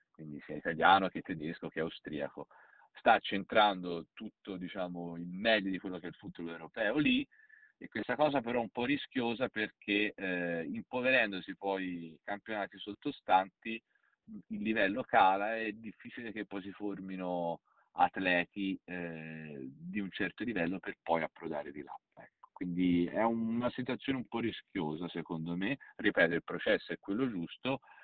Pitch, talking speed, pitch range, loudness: 95 Hz, 155 wpm, 85-115 Hz, -34 LUFS